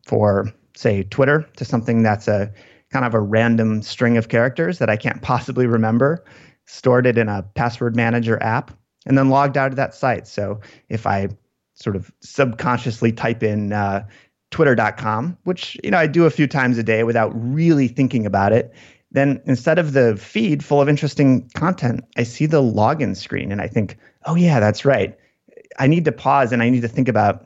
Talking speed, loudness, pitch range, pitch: 195 wpm, -18 LUFS, 110-135 Hz, 120 Hz